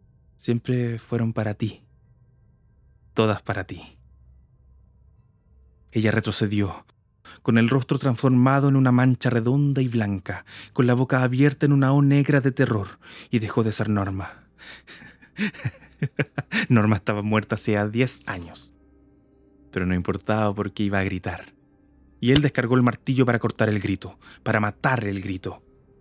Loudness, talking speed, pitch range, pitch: -23 LUFS, 140 wpm, 95-130 Hz, 110 Hz